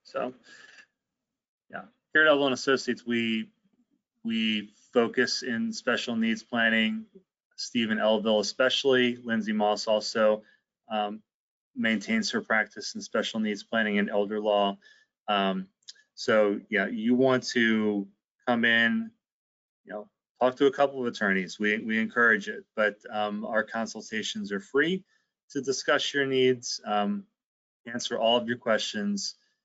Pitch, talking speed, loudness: 120 Hz, 135 wpm, -27 LUFS